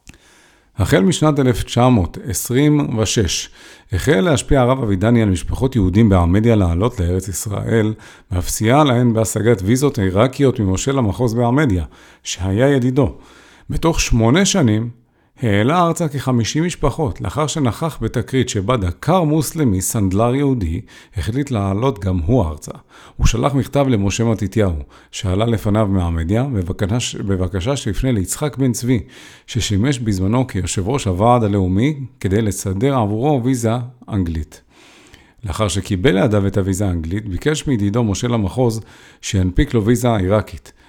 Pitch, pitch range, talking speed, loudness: 115 Hz, 100-130 Hz, 120 wpm, -17 LUFS